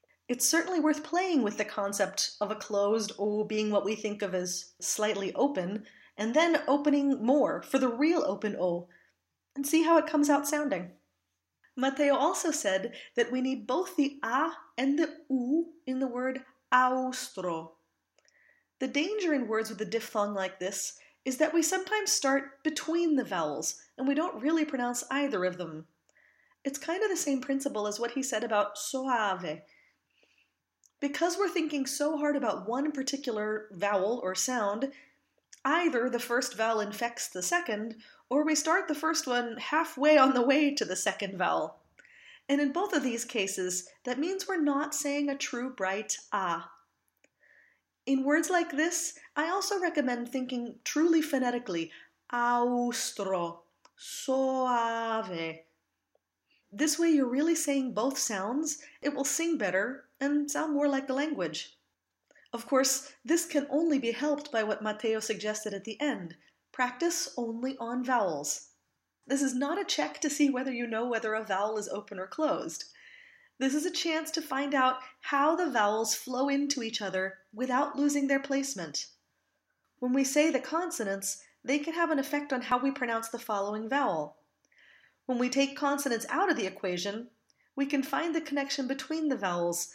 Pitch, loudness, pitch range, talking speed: 265 Hz, -30 LUFS, 220-300 Hz, 165 wpm